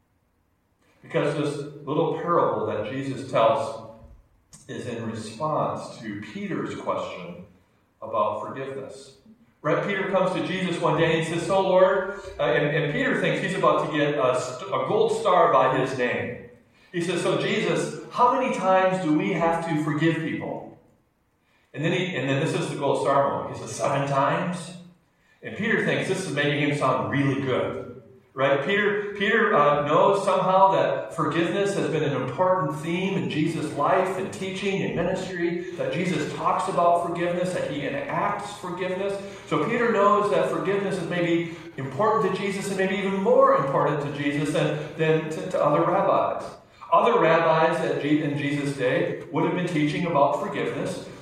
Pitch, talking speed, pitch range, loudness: 165 Hz, 170 wpm, 145-185 Hz, -24 LUFS